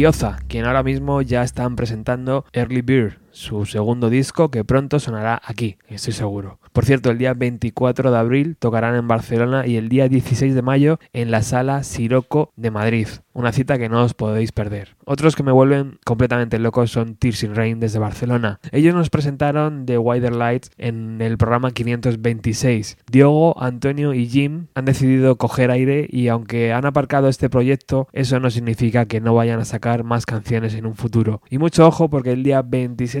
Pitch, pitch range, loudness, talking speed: 125 Hz, 115-135 Hz, -18 LUFS, 185 wpm